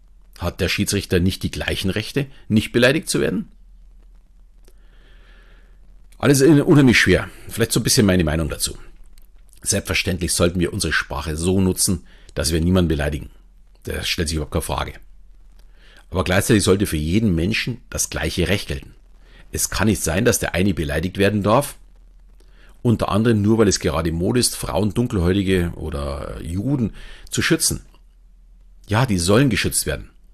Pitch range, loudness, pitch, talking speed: 80-105 Hz, -19 LUFS, 95 Hz, 150 wpm